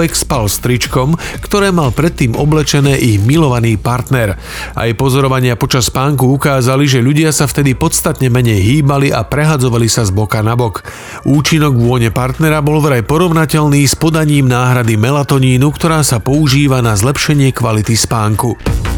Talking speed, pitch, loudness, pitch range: 145 wpm, 135 Hz, -11 LUFS, 120-150 Hz